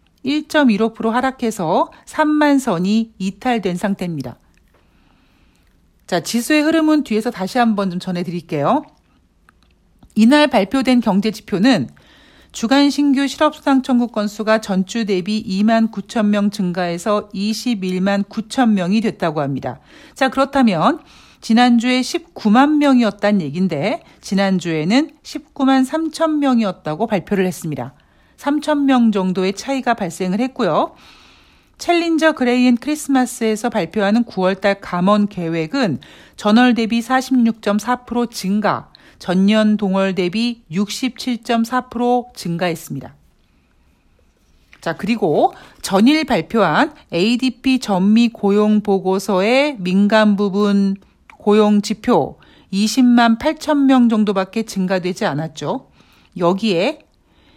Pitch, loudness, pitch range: 215 Hz, -17 LUFS, 190-255 Hz